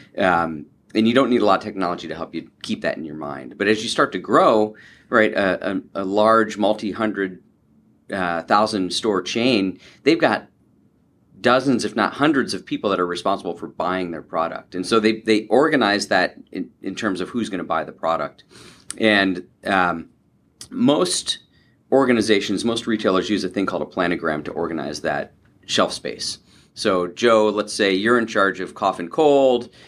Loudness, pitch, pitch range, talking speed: -20 LUFS, 105 Hz, 95-110 Hz, 185 wpm